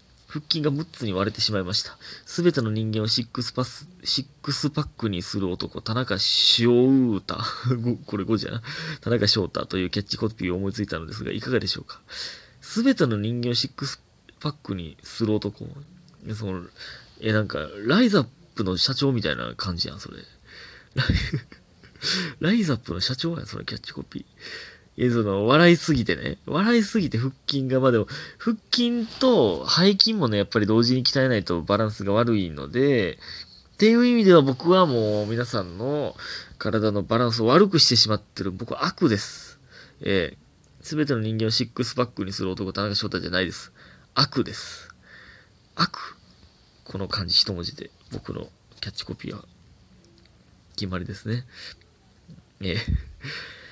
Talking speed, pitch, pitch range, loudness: 315 characters per minute, 115 Hz, 100-145 Hz, -23 LUFS